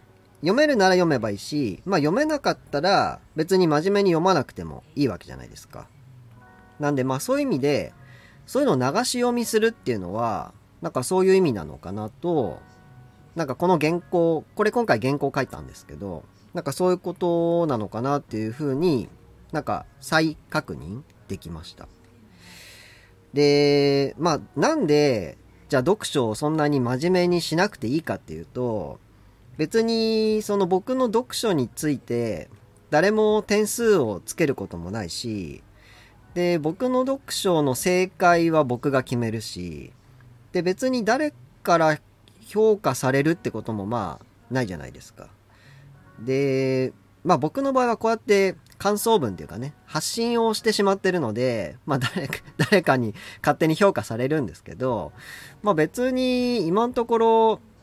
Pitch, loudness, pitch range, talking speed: 145 Hz, -23 LUFS, 115-190 Hz, 315 characters per minute